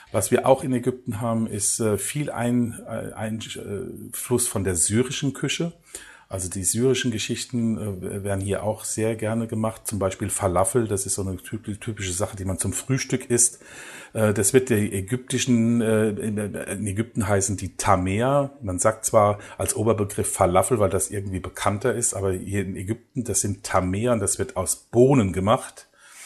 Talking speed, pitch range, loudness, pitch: 160 wpm, 100-120 Hz, -23 LUFS, 110 Hz